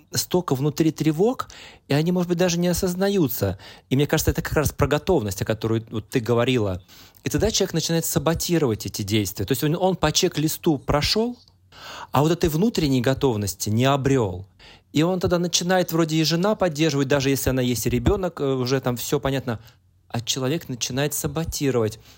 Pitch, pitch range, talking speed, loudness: 140 Hz, 120-165 Hz, 180 wpm, -22 LUFS